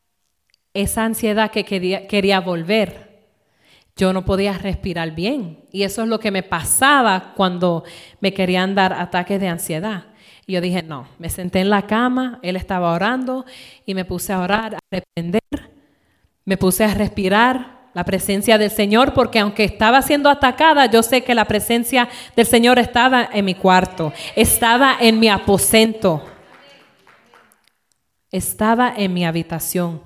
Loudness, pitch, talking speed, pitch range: -17 LUFS, 200 Hz, 150 wpm, 185-230 Hz